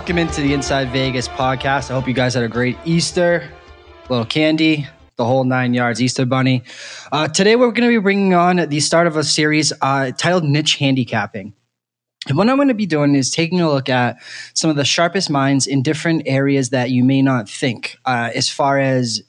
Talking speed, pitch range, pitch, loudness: 215 wpm, 125-160 Hz, 135 Hz, -16 LUFS